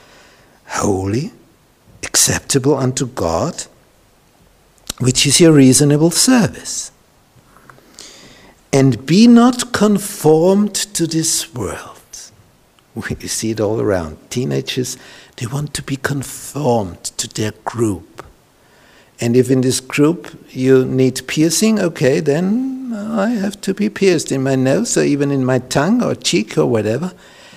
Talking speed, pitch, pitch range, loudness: 125 wpm, 140 Hz, 130-190 Hz, -15 LUFS